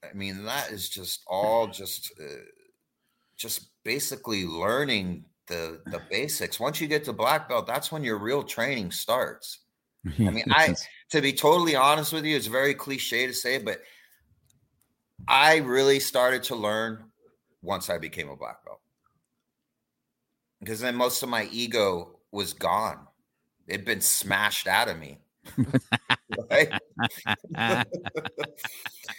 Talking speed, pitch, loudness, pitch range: 135 wpm, 125 Hz, -26 LUFS, 110-140 Hz